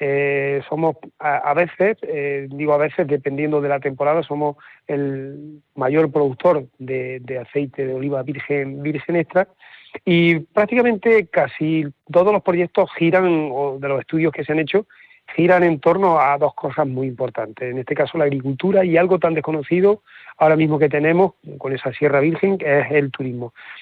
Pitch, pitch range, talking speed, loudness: 150 Hz, 140-170 Hz, 175 wpm, -19 LUFS